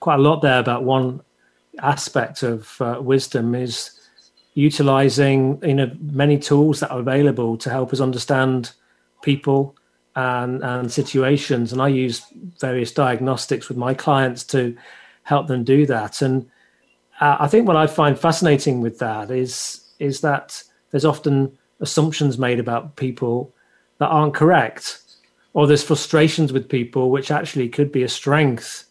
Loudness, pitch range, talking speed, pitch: -19 LUFS, 125-145 Hz, 150 wpm, 135 Hz